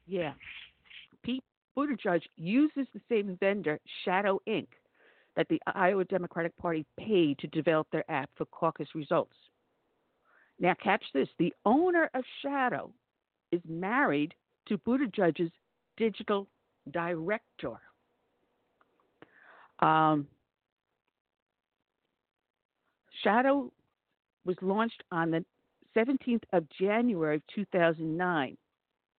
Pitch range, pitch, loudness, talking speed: 165-230 Hz, 190 Hz, -31 LUFS, 95 wpm